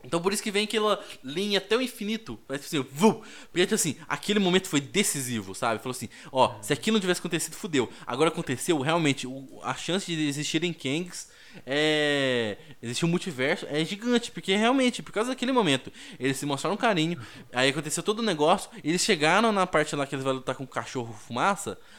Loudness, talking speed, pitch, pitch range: -27 LUFS, 200 wpm, 160 Hz, 135-205 Hz